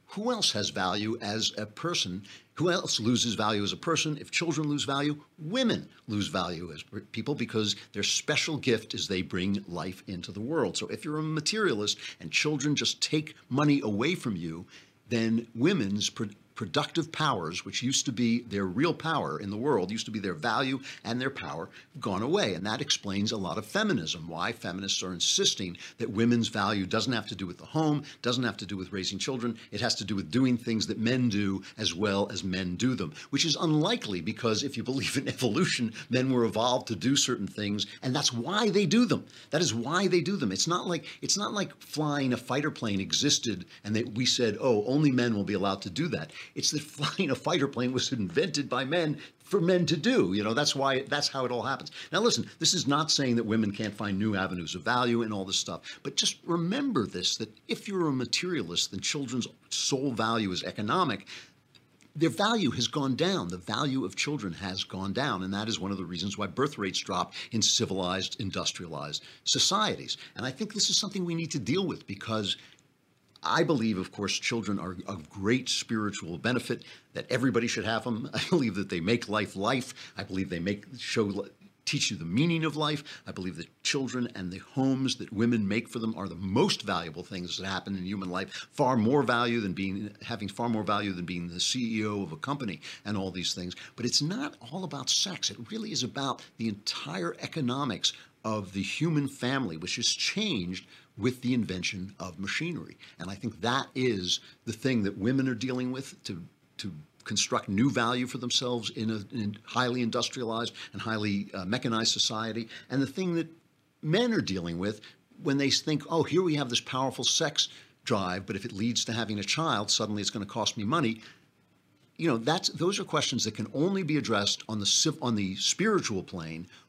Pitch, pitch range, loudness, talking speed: 115 Hz, 100-140 Hz, -29 LUFS, 210 wpm